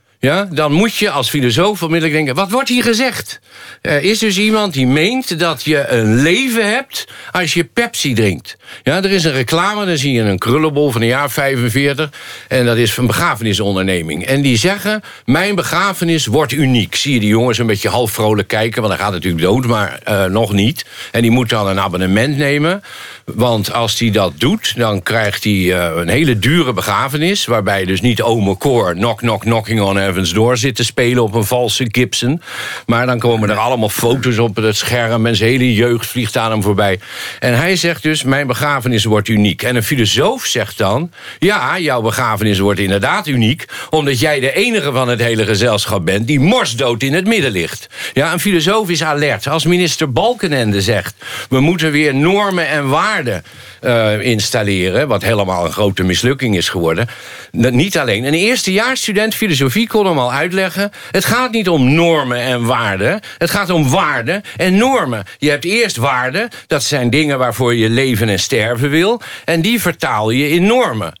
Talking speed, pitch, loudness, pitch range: 190 wpm, 125 Hz, -14 LUFS, 110-165 Hz